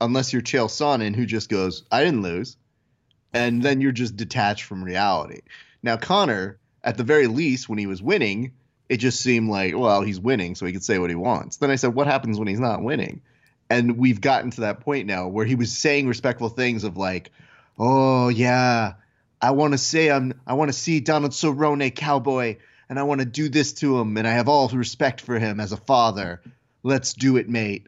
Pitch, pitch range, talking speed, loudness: 125 Hz, 110-135 Hz, 215 wpm, -22 LUFS